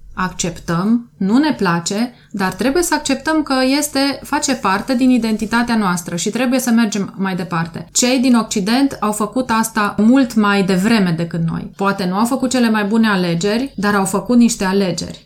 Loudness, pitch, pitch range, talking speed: -16 LUFS, 220 Hz, 195-255 Hz, 175 wpm